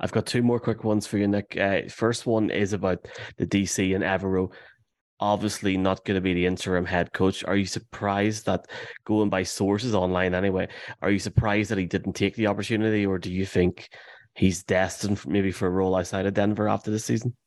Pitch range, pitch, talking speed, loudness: 95-105 Hz, 100 Hz, 215 wpm, -25 LUFS